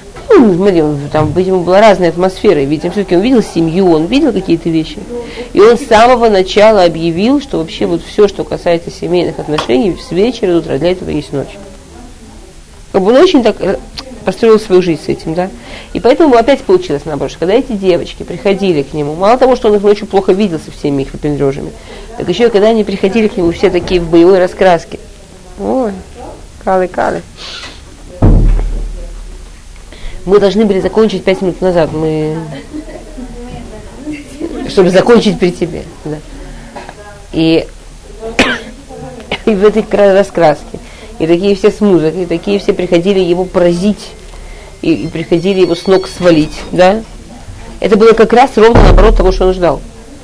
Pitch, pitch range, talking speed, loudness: 185 Hz, 160-215 Hz, 160 wpm, -10 LUFS